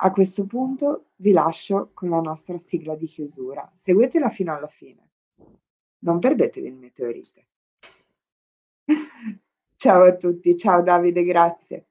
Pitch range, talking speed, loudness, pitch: 165-200 Hz, 125 wpm, -20 LUFS, 175 Hz